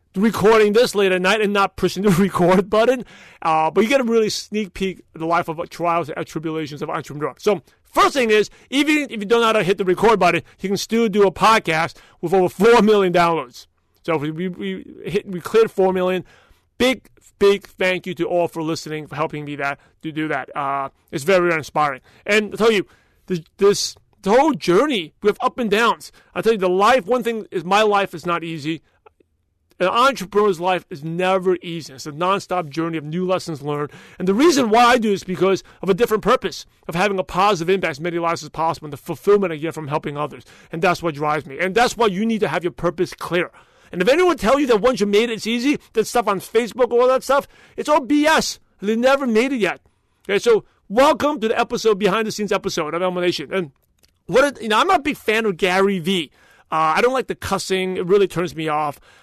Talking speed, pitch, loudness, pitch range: 235 wpm, 190 Hz, -19 LUFS, 165-220 Hz